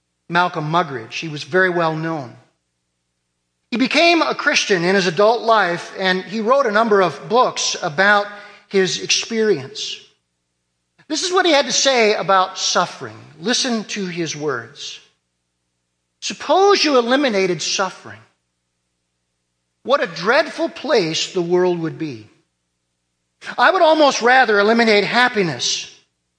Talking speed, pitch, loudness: 125 wpm, 185 Hz, -17 LUFS